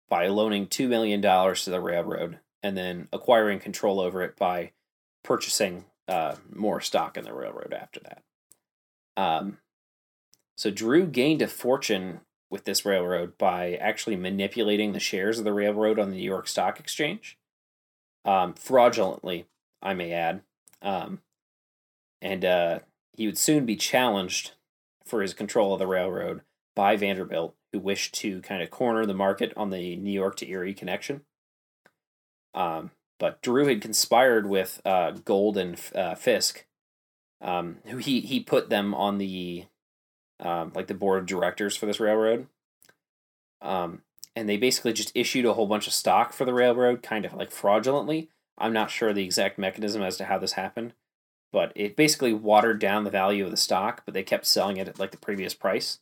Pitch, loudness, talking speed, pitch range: 100 Hz, -26 LUFS, 170 wpm, 90-110 Hz